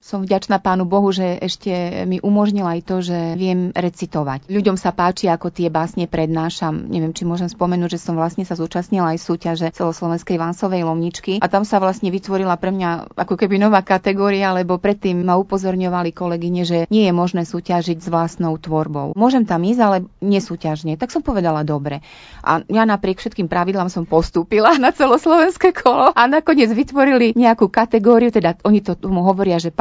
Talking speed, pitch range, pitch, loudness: 175 wpm, 170-200 Hz, 185 Hz, -17 LUFS